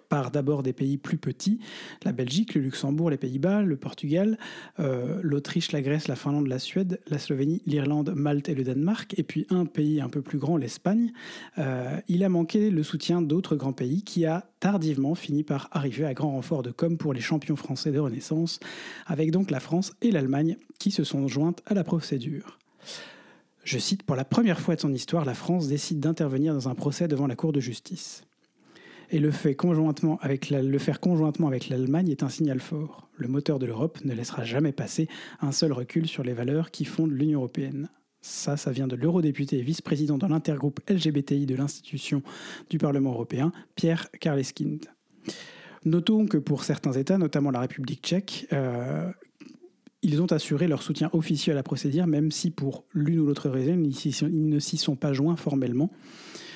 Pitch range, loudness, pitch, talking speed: 140-170 Hz, -27 LUFS, 155 Hz, 190 wpm